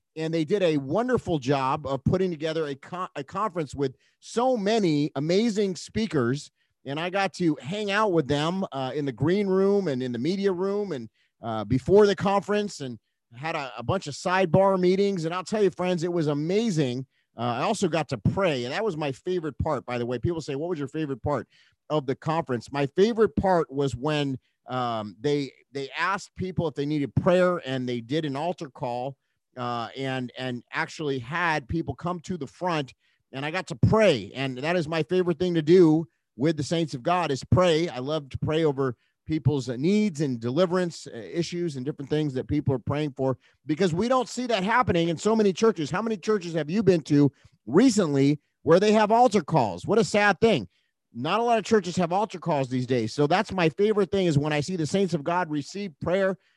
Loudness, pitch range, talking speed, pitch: -25 LUFS, 140-190 Hz, 215 wpm, 160 Hz